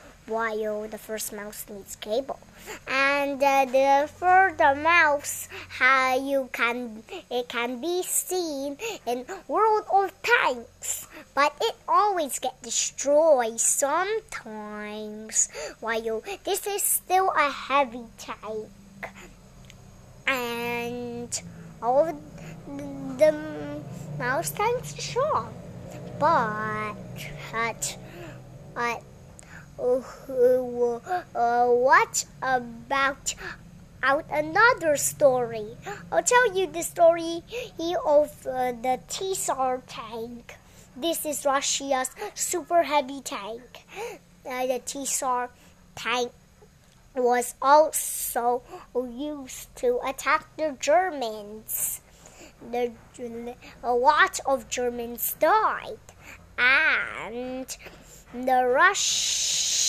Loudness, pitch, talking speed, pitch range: -25 LUFS, 265 Hz, 90 wpm, 240-335 Hz